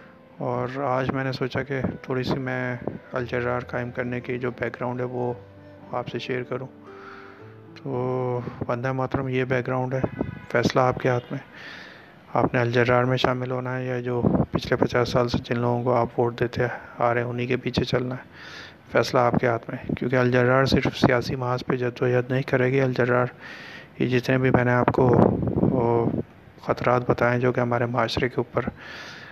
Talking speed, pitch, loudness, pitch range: 195 wpm, 125 Hz, -24 LUFS, 120-130 Hz